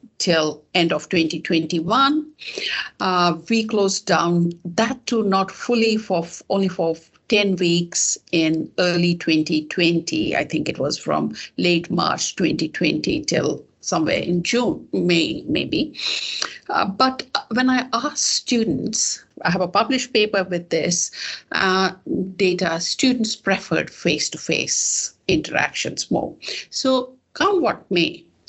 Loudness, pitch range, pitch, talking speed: -20 LUFS, 170-230 Hz, 185 Hz, 120 wpm